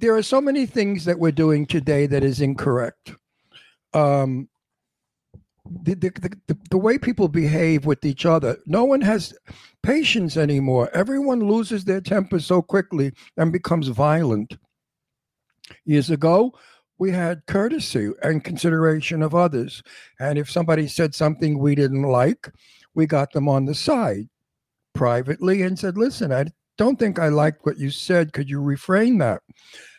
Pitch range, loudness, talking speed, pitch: 145-190 Hz, -21 LUFS, 150 wpm, 160 Hz